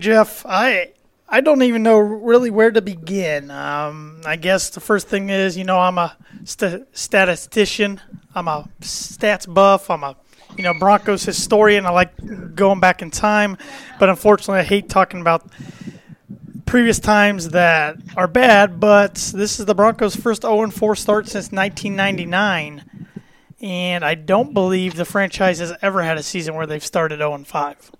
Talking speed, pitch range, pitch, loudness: 160 wpm, 175-210 Hz, 195 Hz, -17 LUFS